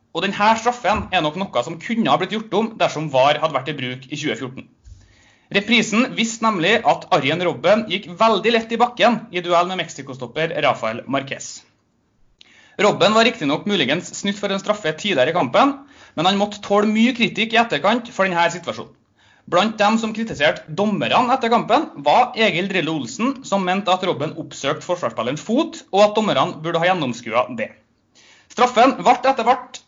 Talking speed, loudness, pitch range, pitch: 175 wpm, -19 LUFS, 160-225 Hz, 200 Hz